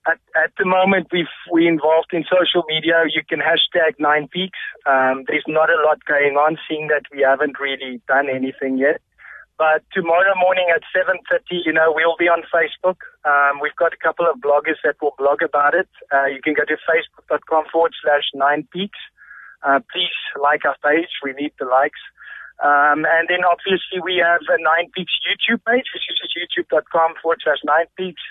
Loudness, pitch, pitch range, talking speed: -18 LUFS, 165 Hz, 145-175 Hz, 195 wpm